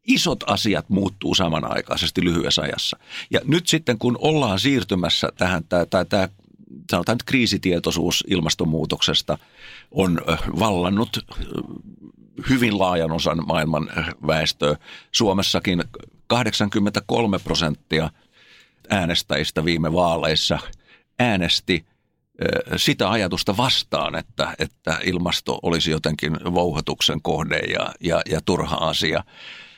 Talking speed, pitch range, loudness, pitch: 90 wpm, 80-110 Hz, -21 LUFS, 90 Hz